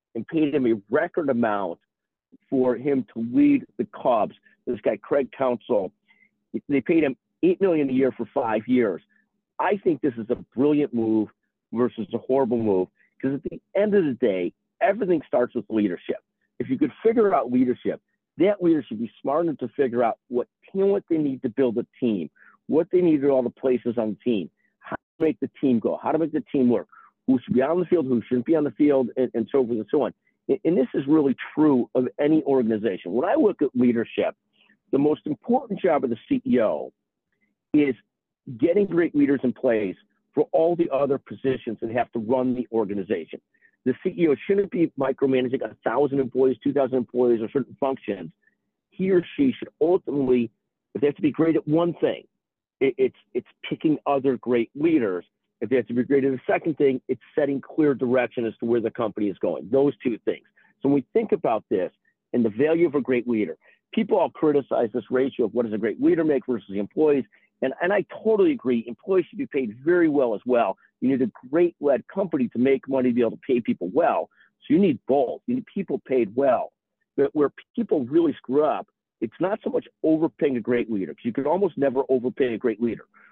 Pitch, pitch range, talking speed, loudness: 135 Hz, 125-165 Hz, 215 wpm, -24 LUFS